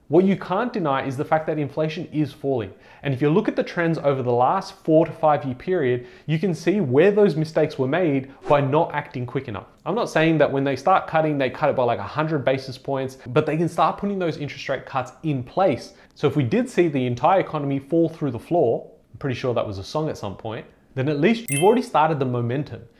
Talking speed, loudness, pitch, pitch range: 250 wpm, -22 LUFS, 145 Hz, 130-160 Hz